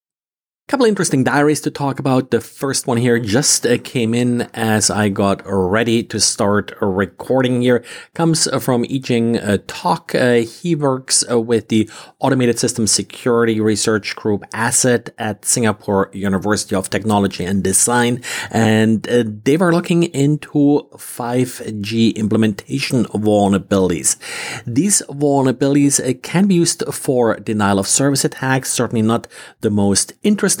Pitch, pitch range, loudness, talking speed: 120 Hz, 110-135 Hz, -16 LUFS, 130 wpm